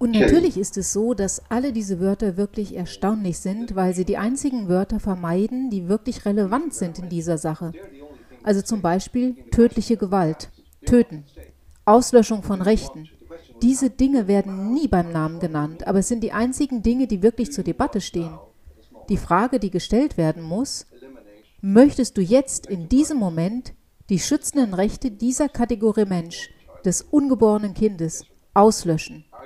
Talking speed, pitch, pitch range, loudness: 150 wpm, 205 Hz, 180-240 Hz, -21 LUFS